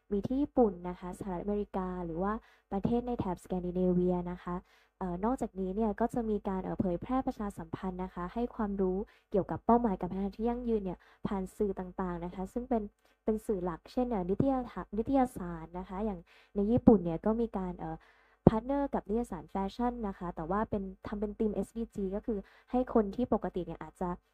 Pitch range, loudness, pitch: 180-230 Hz, -34 LUFS, 200 Hz